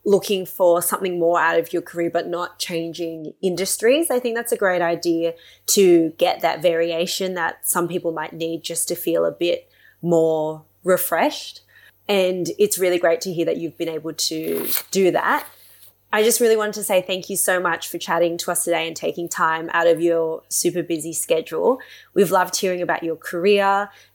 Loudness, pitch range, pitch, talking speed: -20 LUFS, 165-190 Hz, 175 Hz, 190 wpm